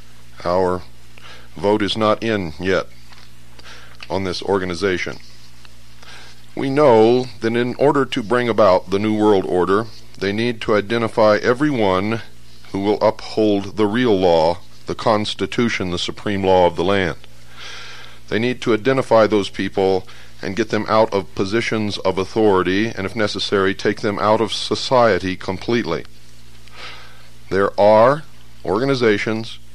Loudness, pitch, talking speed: -18 LUFS, 100 Hz, 135 wpm